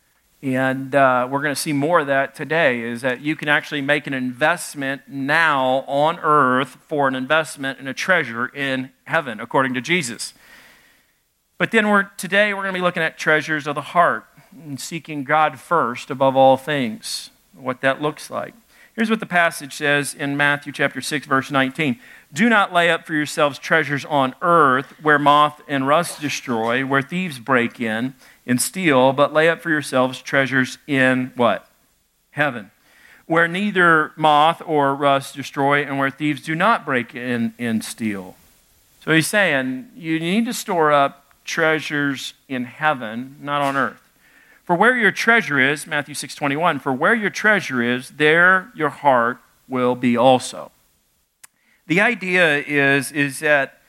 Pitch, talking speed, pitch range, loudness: 145 Hz, 165 wpm, 135-165 Hz, -19 LUFS